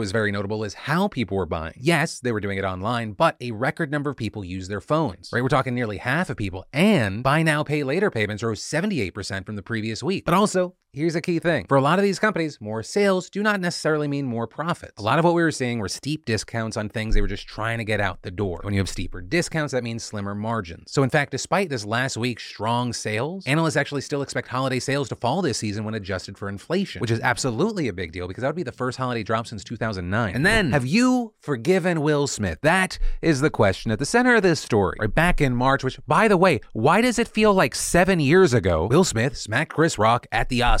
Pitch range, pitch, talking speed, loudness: 110-165 Hz, 130 Hz, 255 wpm, -23 LUFS